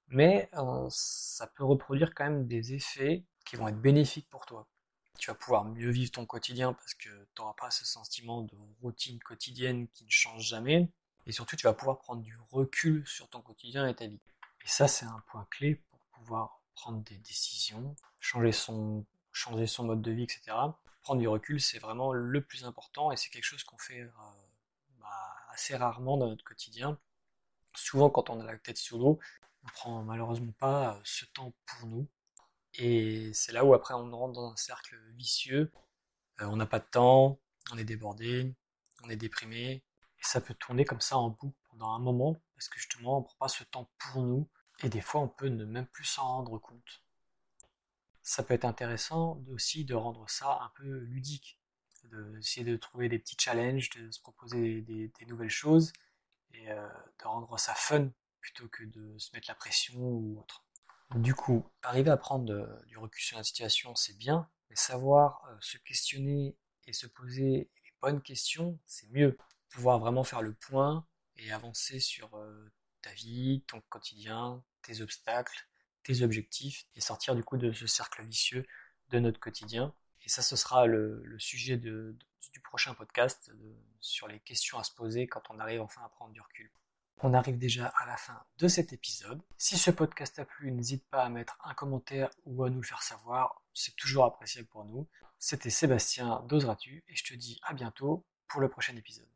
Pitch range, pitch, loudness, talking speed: 110-135 Hz, 125 Hz, -32 LUFS, 195 wpm